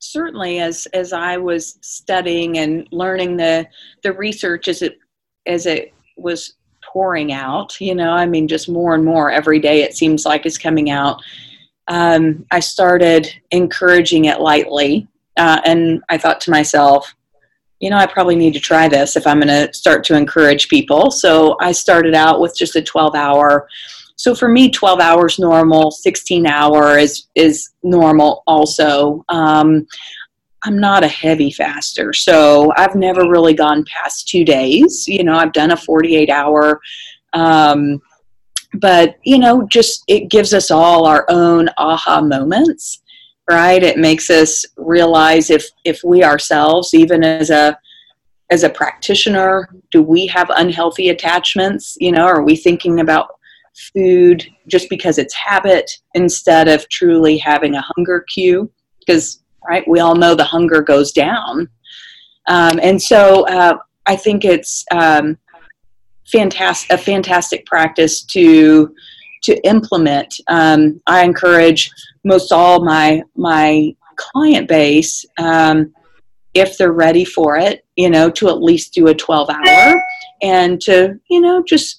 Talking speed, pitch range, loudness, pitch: 150 wpm, 155-185 Hz, -12 LUFS, 170 Hz